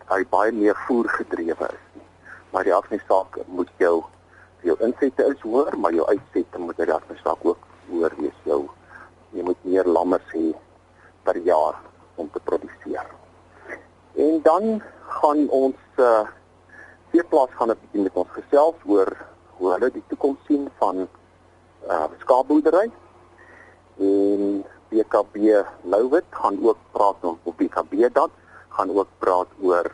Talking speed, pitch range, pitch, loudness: 150 wpm, 95-150 Hz, 110 Hz, -22 LUFS